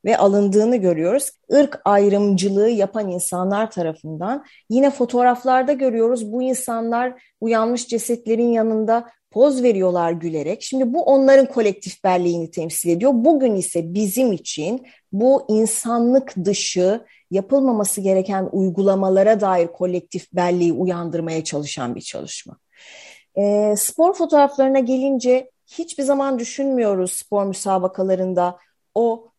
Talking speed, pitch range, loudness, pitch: 110 wpm, 185-255 Hz, -19 LUFS, 215 Hz